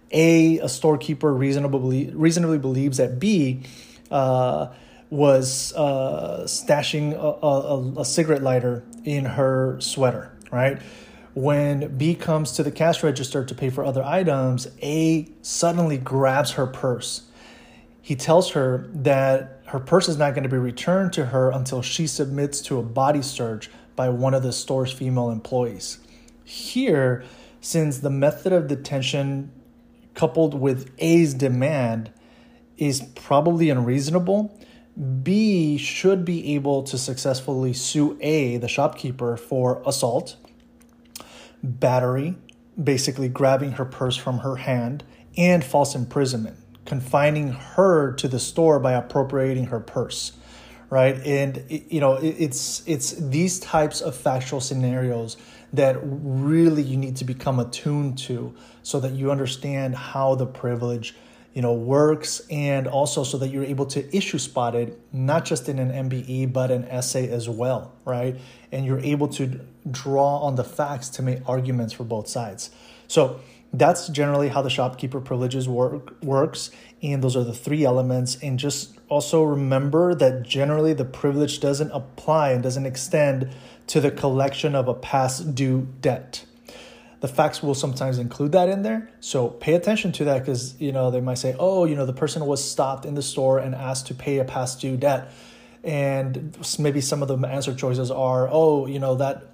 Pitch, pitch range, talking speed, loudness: 135 Hz, 130-150 Hz, 155 wpm, -23 LUFS